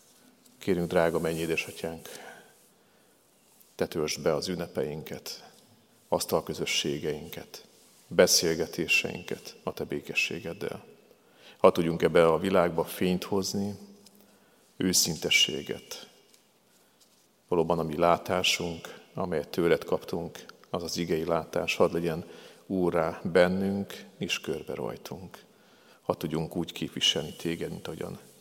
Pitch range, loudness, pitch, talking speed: 80-95 Hz, -28 LUFS, 85 Hz, 100 wpm